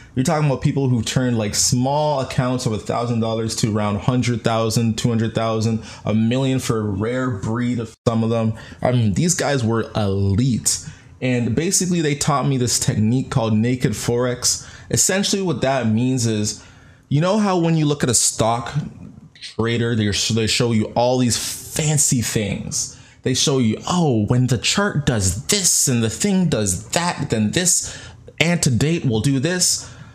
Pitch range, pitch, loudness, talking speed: 110-145 Hz, 125 Hz, -19 LUFS, 165 wpm